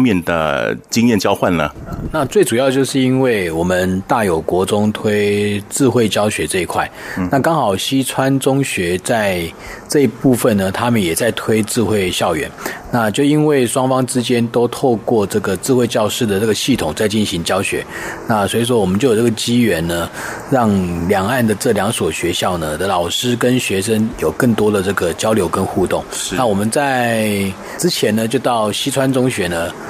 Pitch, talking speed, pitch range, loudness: 115 Hz, 265 characters per minute, 100-130 Hz, -16 LUFS